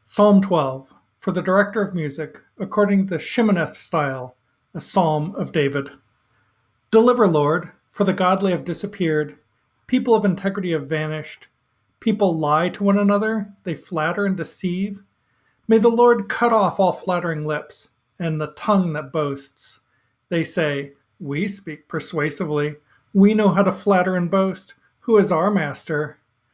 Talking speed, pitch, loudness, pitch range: 150 wpm, 180 Hz, -20 LUFS, 150-200 Hz